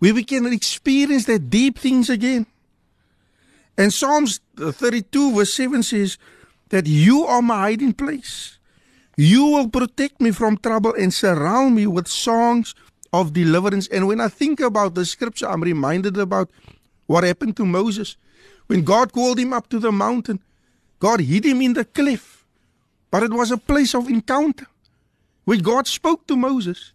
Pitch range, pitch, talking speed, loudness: 205-260 Hz, 235 Hz, 165 wpm, -19 LUFS